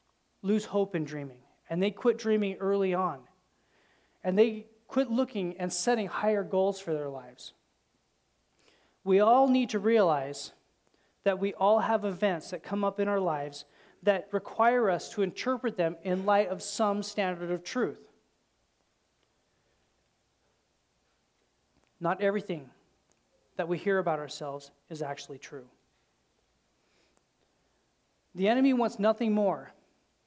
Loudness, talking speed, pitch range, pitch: -29 LUFS, 130 wpm, 170-215 Hz, 195 Hz